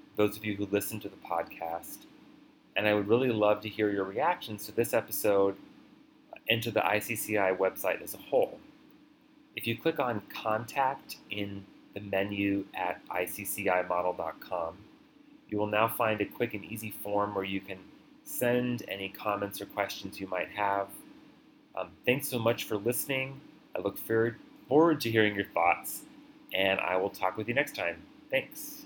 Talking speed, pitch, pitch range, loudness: 170 wpm, 105 Hz, 100-125 Hz, -31 LUFS